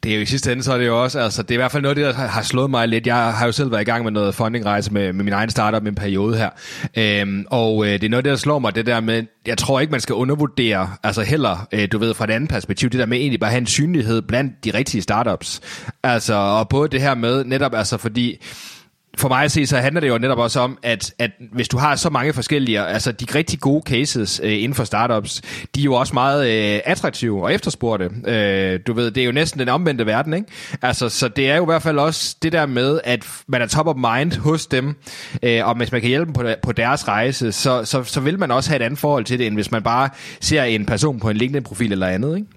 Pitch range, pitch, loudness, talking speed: 110-140 Hz, 125 Hz, -19 LUFS, 275 wpm